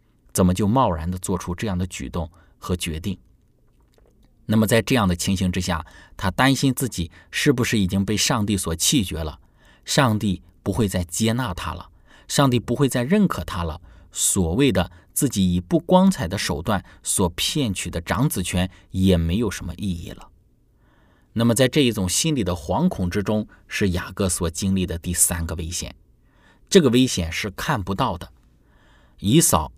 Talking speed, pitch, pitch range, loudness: 250 characters per minute, 95 Hz, 90-115 Hz, -22 LUFS